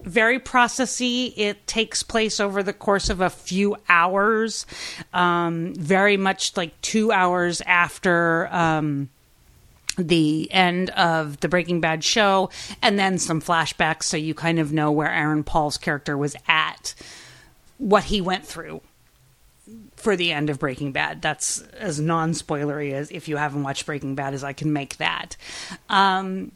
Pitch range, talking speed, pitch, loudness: 155-200 Hz, 155 wpm, 175 Hz, -22 LUFS